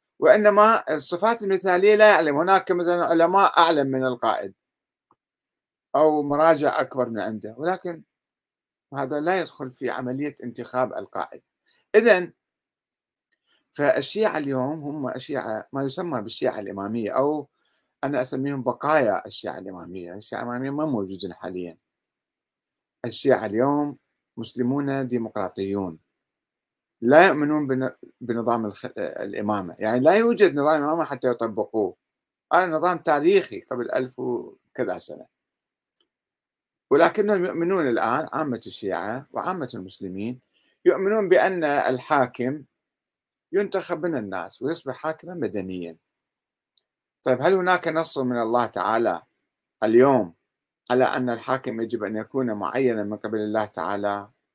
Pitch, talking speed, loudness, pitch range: 130 Hz, 110 wpm, -23 LUFS, 115-170 Hz